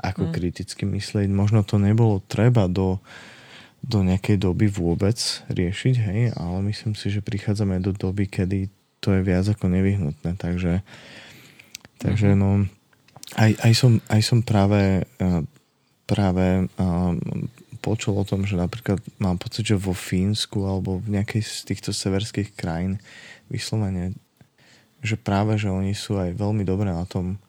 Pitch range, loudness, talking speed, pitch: 95-110 Hz, -23 LUFS, 145 wpm, 100 Hz